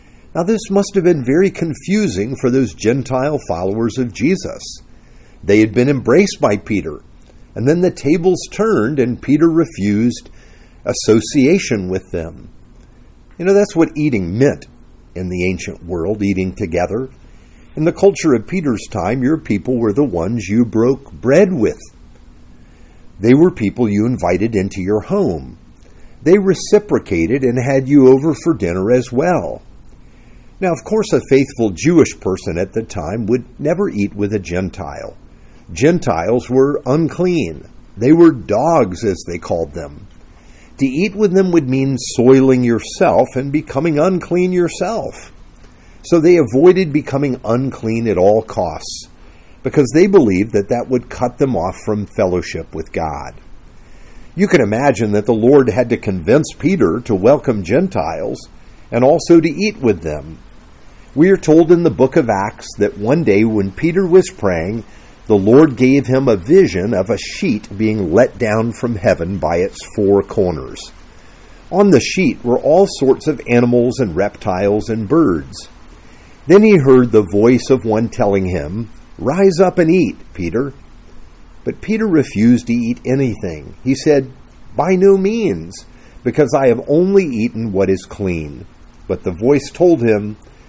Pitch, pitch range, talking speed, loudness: 120 Hz, 95-150 Hz, 155 wpm, -15 LUFS